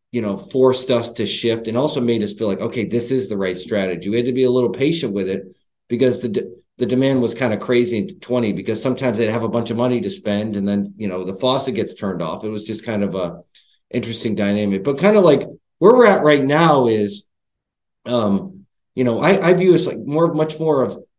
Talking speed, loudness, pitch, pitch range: 245 wpm, -18 LUFS, 120 Hz, 105-130 Hz